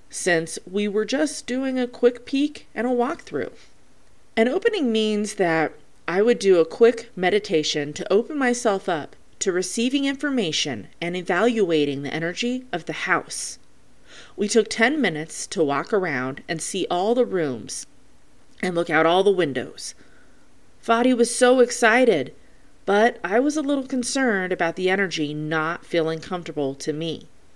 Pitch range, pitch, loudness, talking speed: 165-240 Hz, 205 Hz, -22 LUFS, 155 wpm